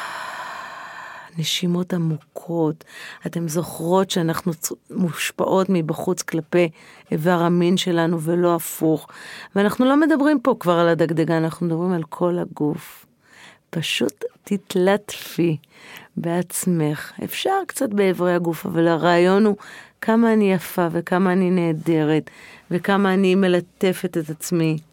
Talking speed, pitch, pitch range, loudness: 115 wpm, 175 Hz, 165-195 Hz, -21 LUFS